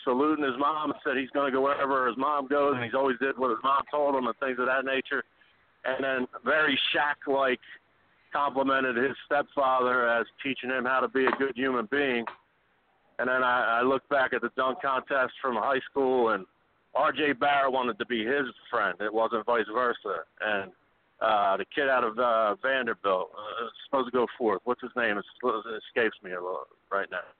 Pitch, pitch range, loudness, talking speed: 135 Hz, 125-140 Hz, -28 LUFS, 205 wpm